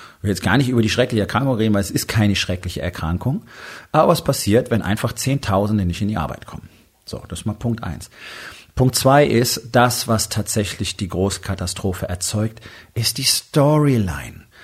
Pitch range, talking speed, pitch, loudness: 95-125 Hz, 185 wpm, 110 Hz, -19 LUFS